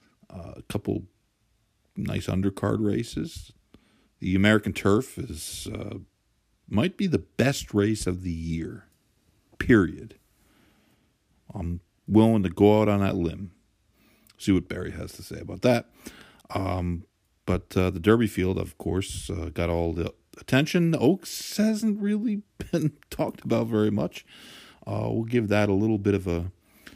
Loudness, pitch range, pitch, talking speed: -26 LUFS, 90-110 Hz, 100 Hz, 145 wpm